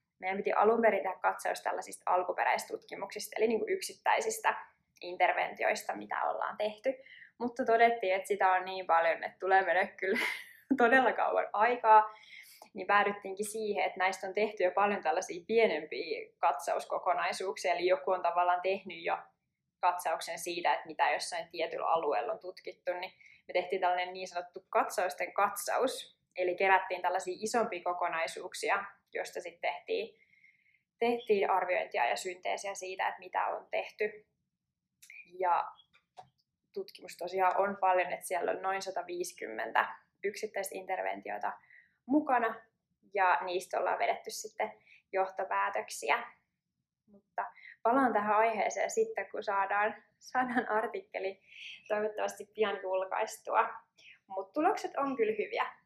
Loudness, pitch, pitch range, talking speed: -32 LUFS, 200 Hz, 185-230 Hz, 125 wpm